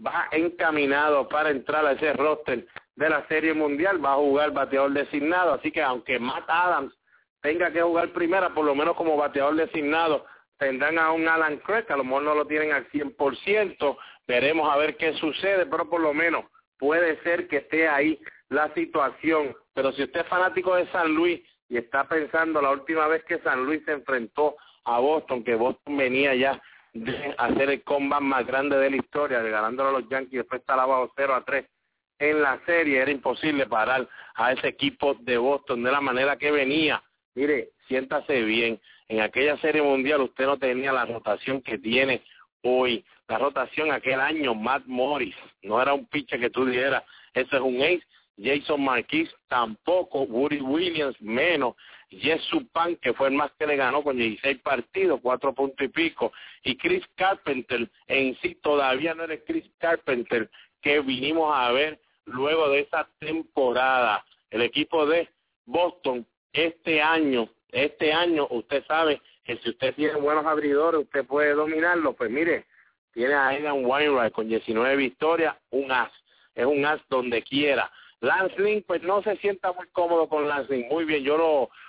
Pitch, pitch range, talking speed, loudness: 145 Hz, 135-160 Hz, 175 wpm, -25 LUFS